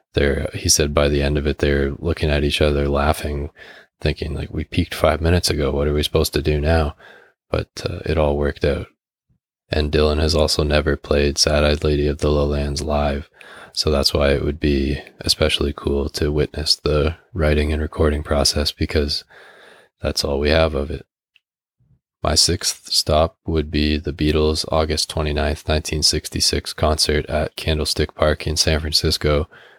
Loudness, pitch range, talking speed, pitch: -19 LUFS, 70-80 Hz, 175 wpm, 75 Hz